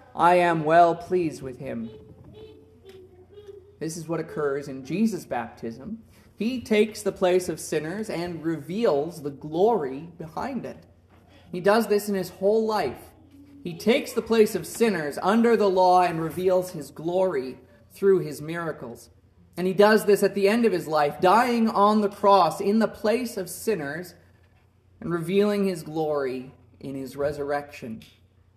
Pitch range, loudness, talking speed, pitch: 135-200 Hz, -24 LUFS, 155 wpm, 170 Hz